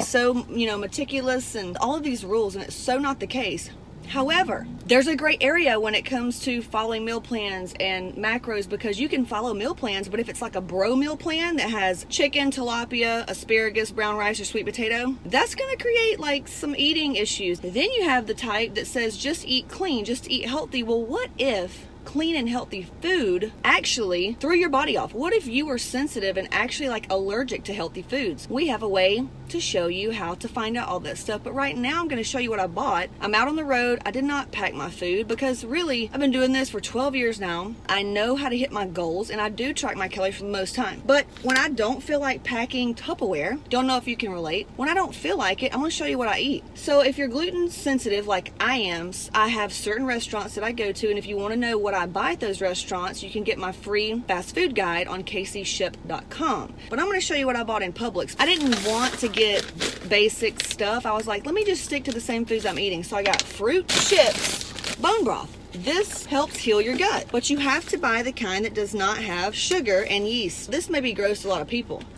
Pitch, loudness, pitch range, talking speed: 235 Hz, -24 LUFS, 210-275 Hz, 240 wpm